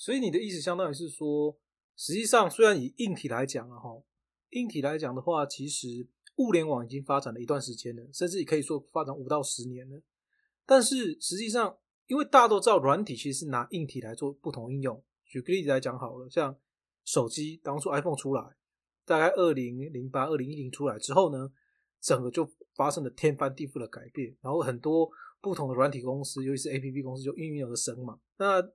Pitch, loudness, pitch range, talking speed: 145 Hz, -29 LUFS, 130-175 Hz, 325 characters per minute